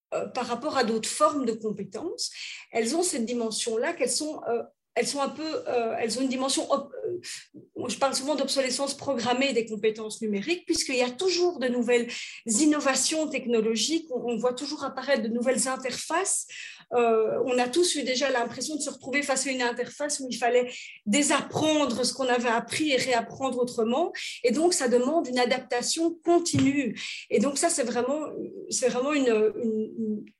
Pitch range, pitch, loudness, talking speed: 240-295 Hz, 255 Hz, -26 LUFS, 170 wpm